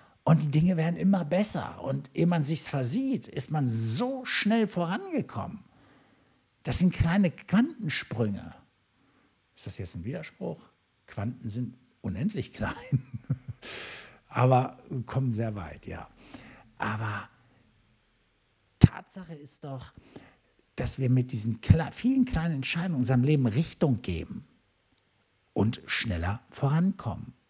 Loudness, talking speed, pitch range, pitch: -29 LUFS, 120 wpm, 115-170 Hz, 130 Hz